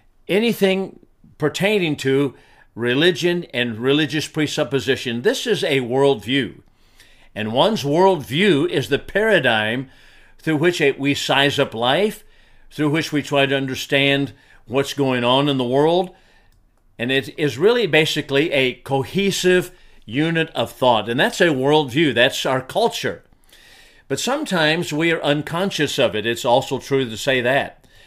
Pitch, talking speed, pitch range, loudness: 140 Hz, 140 wpm, 130-165 Hz, -19 LUFS